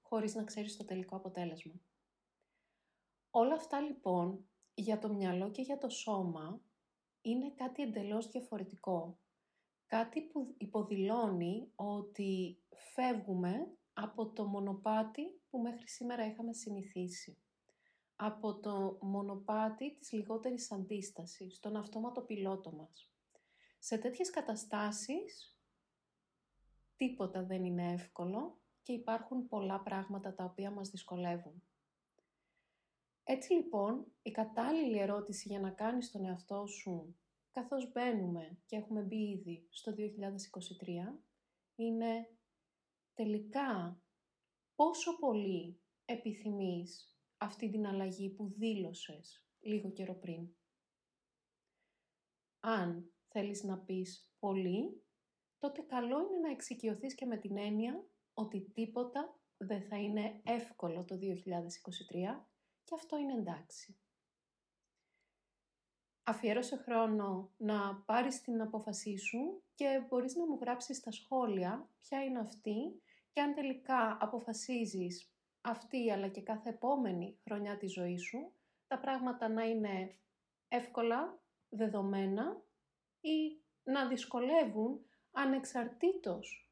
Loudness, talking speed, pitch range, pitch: -40 LUFS, 110 wpm, 195-245 Hz, 215 Hz